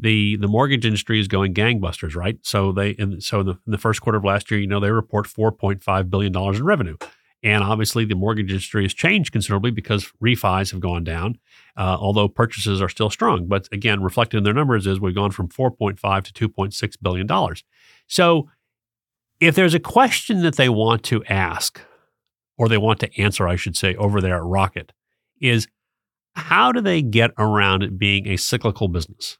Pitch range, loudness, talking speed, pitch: 95-115 Hz, -20 LUFS, 205 wpm, 105 Hz